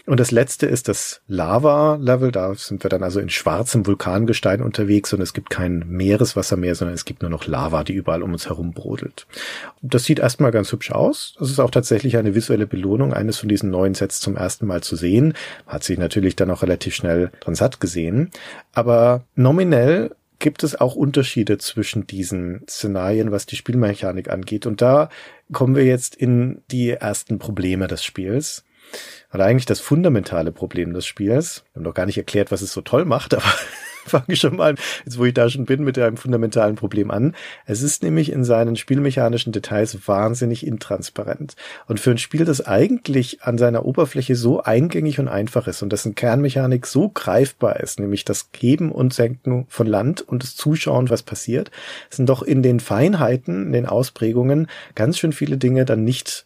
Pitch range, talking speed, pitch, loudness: 100-130 Hz, 190 wpm, 115 Hz, -19 LUFS